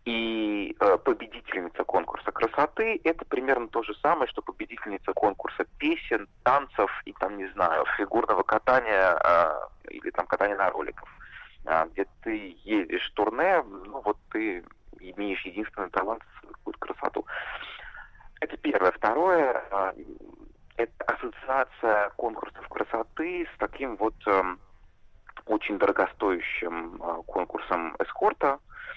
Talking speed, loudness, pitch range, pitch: 120 wpm, -28 LUFS, 225-360 Hz, 330 Hz